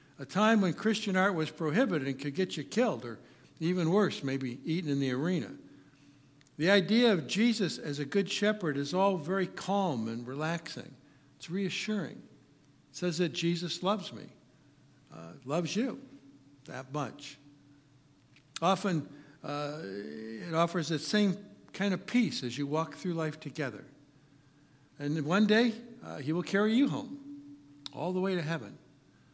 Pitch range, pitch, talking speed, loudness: 145-195 Hz, 160 Hz, 155 wpm, -31 LUFS